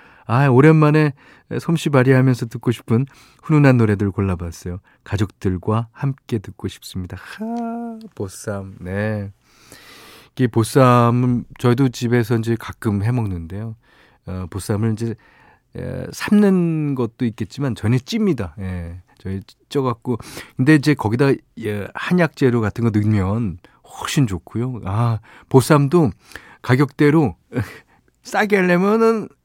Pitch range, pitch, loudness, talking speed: 105-140 Hz, 120 Hz, -19 LUFS, 250 characters per minute